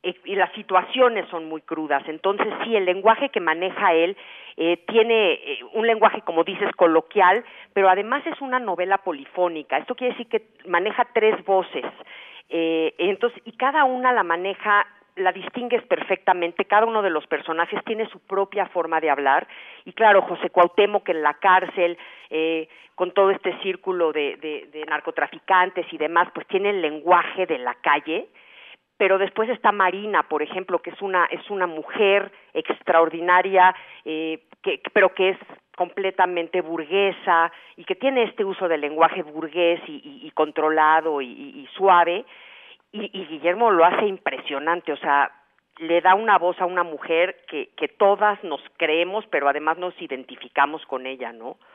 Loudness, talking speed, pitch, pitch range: -21 LUFS, 165 wpm, 185 Hz, 165-210 Hz